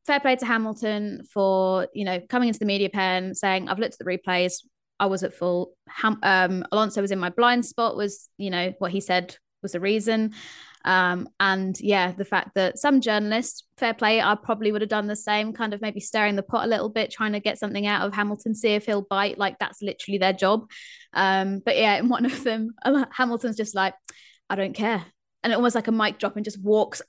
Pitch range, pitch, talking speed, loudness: 190-225 Hz, 210 Hz, 230 wpm, -24 LUFS